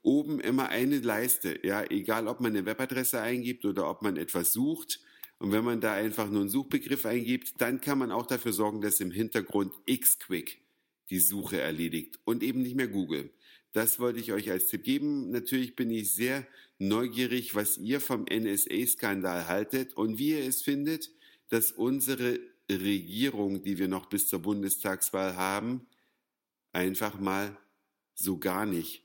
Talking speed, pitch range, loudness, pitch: 165 wpm, 100-130 Hz, -30 LUFS, 115 Hz